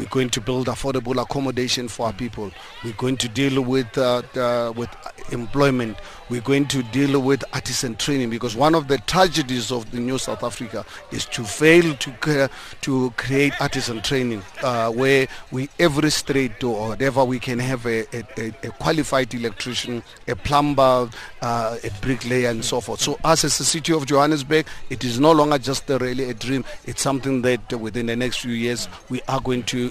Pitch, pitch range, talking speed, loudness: 130 Hz, 120-135 Hz, 190 wpm, -21 LUFS